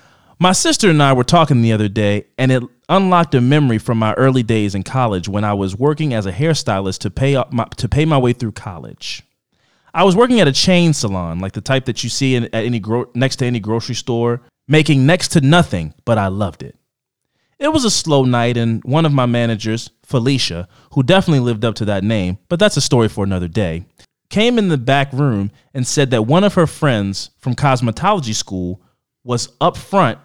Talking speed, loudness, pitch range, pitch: 220 wpm, -16 LUFS, 110-145 Hz, 125 Hz